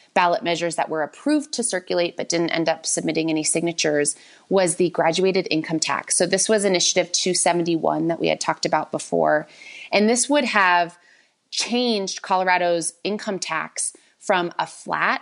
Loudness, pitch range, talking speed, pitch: -21 LUFS, 160-190 Hz, 160 wpm, 175 Hz